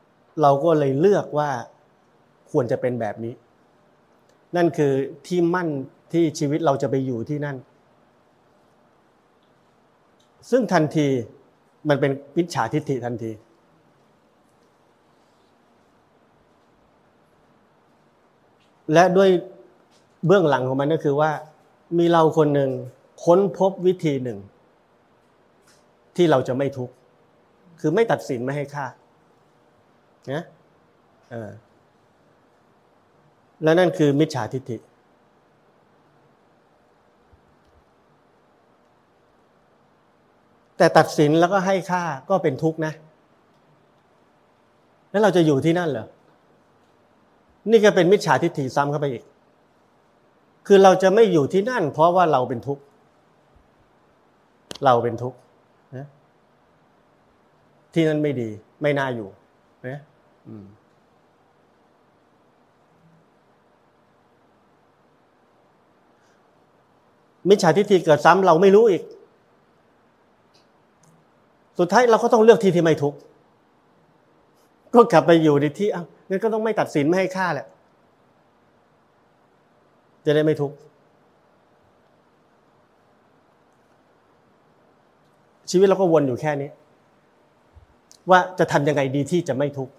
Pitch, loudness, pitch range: 150 Hz, -20 LUFS, 135-175 Hz